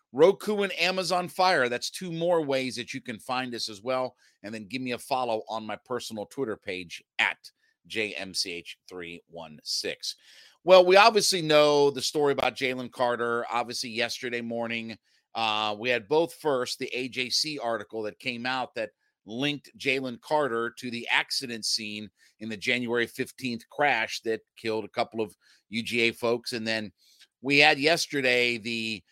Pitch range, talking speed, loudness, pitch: 110-140 Hz, 160 wpm, -27 LUFS, 120 Hz